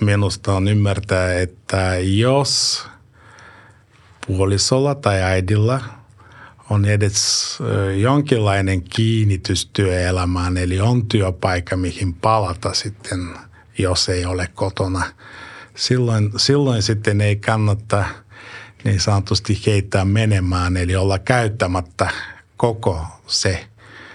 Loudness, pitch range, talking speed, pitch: -18 LUFS, 95-110 Hz, 90 wpm, 100 Hz